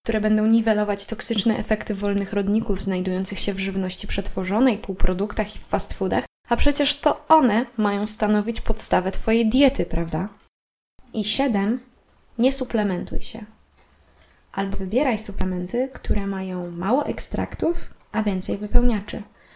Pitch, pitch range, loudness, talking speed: 210 Hz, 195-235 Hz, -22 LUFS, 125 wpm